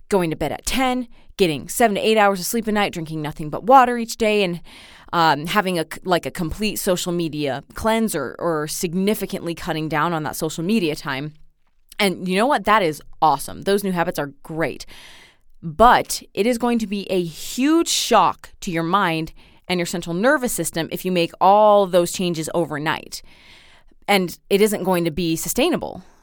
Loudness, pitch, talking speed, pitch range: -20 LUFS, 180 Hz, 190 wpm, 160-210 Hz